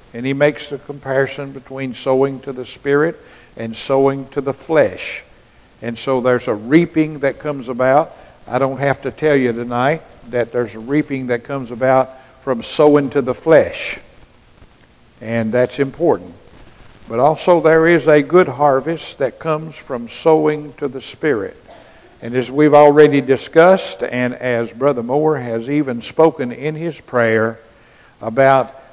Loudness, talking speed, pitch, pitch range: -16 LUFS, 155 wpm, 135 Hz, 125-150 Hz